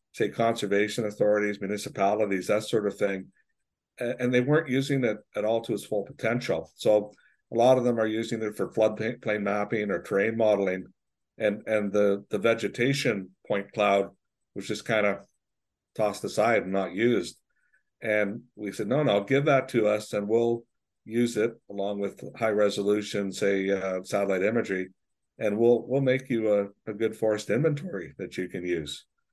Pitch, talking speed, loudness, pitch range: 105 Hz, 175 wpm, -27 LUFS, 100-115 Hz